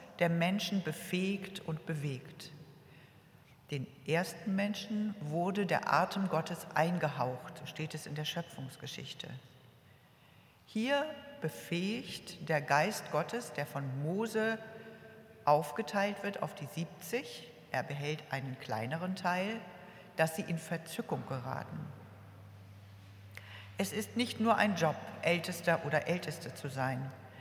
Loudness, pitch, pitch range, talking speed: -36 LUFS, 160 Hz, 140-195 Hz, 115 wpm